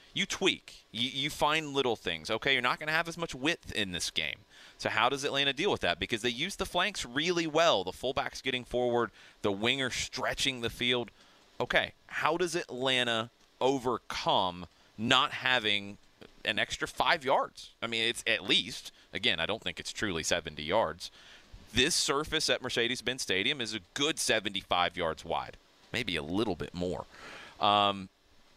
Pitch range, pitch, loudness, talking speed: 110-140 Hz, 125 Hz, -30 LUFS, 175 wpm